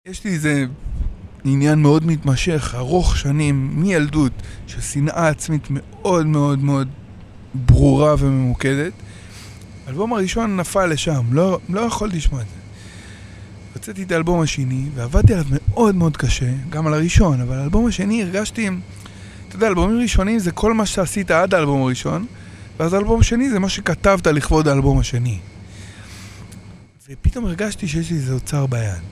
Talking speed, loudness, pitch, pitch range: 145 wpm, -18 LUFS, 140 Hz, 110-175 Hz